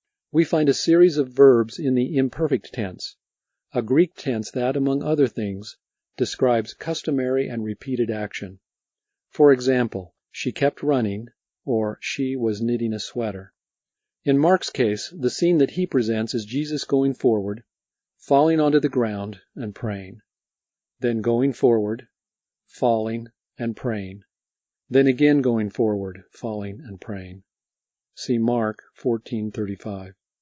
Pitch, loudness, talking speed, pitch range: 120 Hz, -22 LUFS, 130 wpm, 105-140 Hz